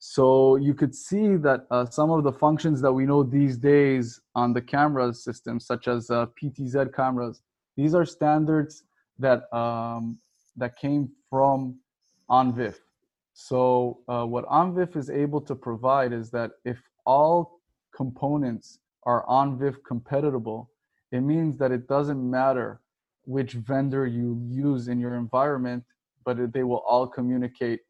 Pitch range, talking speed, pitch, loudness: 120-140 Hz, 145 wpm, 130 Hz, -25 LUFS